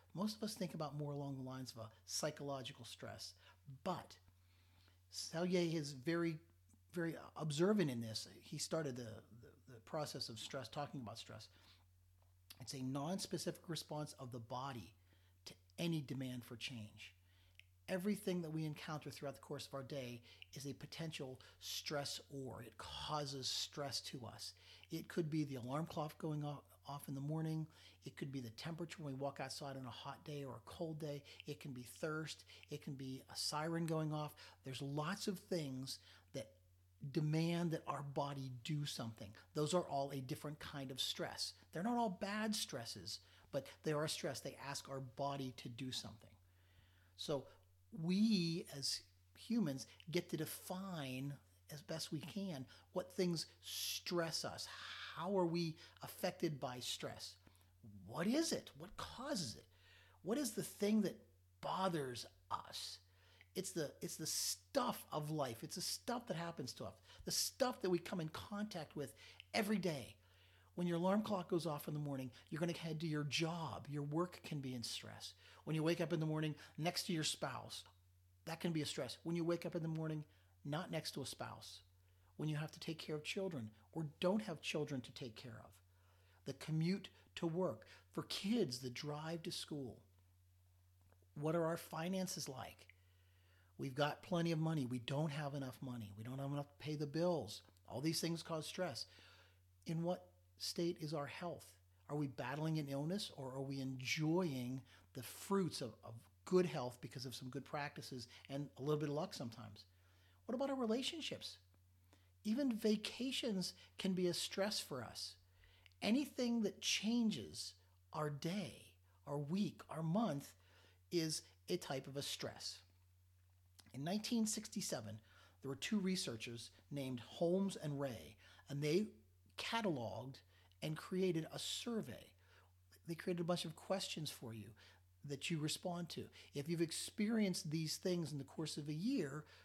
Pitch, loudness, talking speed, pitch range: 140 Hz, -44 LUFS, 170 wpm, 100-165 Hz